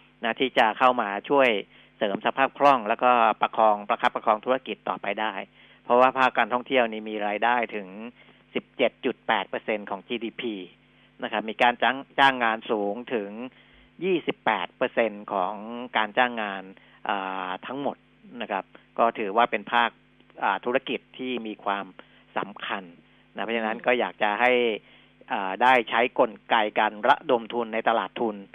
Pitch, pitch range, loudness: 115 Hz, 105-125 Hz, -25 LUFS